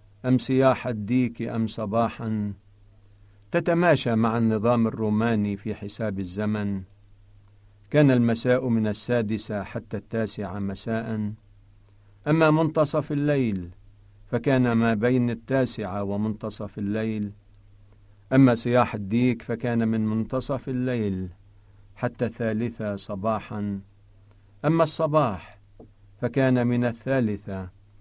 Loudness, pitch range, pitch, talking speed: -25 LUFS, 100-120 Hz, 110 Hz, 90 wpm